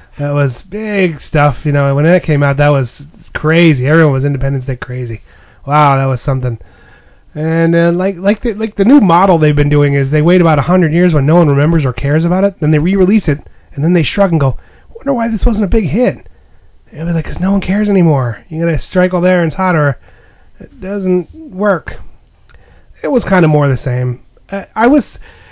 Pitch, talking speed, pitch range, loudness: 155 Hz, 220 wpm, 135-185 Hz, -11 LUFS